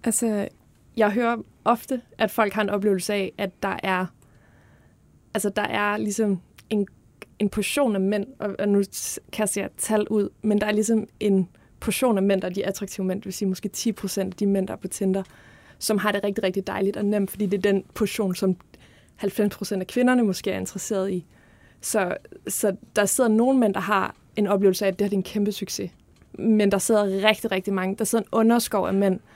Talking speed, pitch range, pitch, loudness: 215 wpm, 195-215 Hz, 205 Hz, -24 LUFS